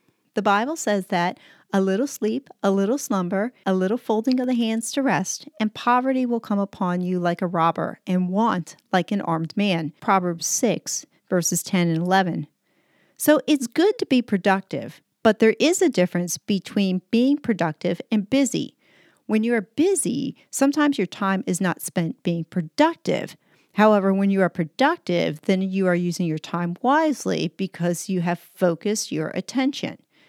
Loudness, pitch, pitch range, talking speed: -22 LUFS, 195 Hz, 180-245 Hz, 170 wpm